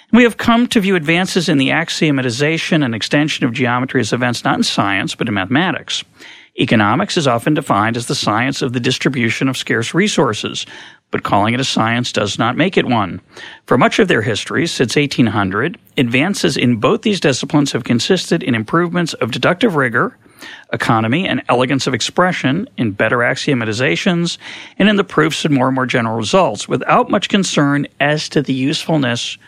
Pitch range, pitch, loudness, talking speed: 125-165 Hz, 140 Hz, -15 LUFS, 180 wpm